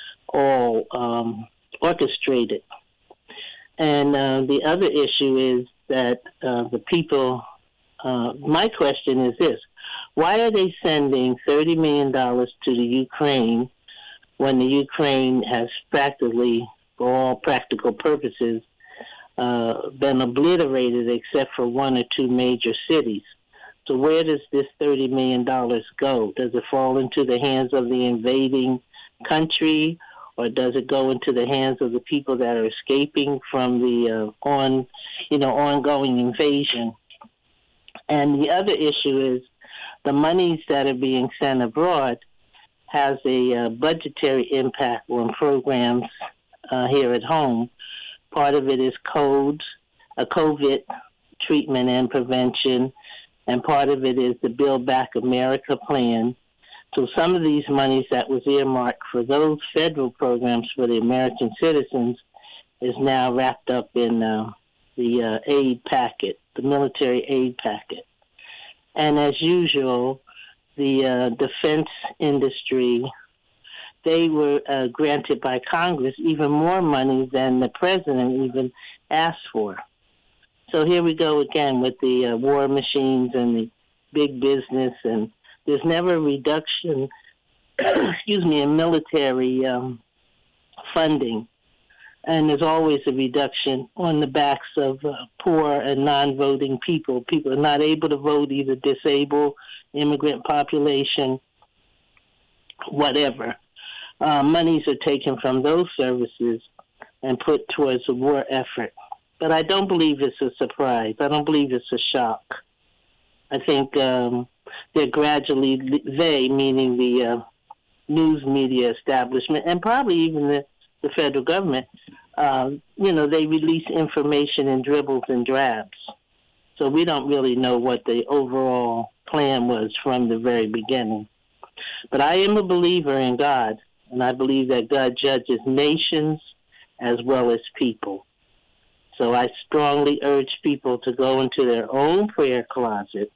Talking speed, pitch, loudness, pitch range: 135 wpm, 135 Hz, -21 LUFS, 125-150 Hz